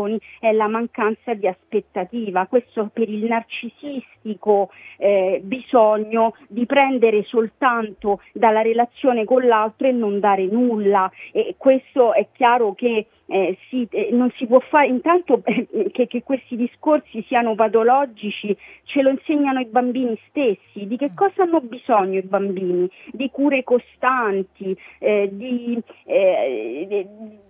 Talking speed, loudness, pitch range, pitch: 135 wpm, -20 LUFS, 210-255 Hz, 235 Hz